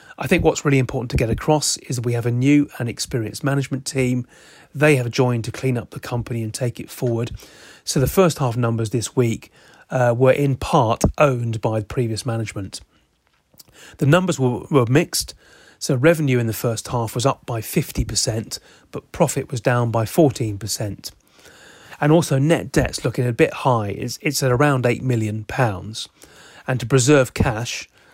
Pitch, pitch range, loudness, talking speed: 125 Hz, 115-135 Hz, -20 LUFS, 180 wpm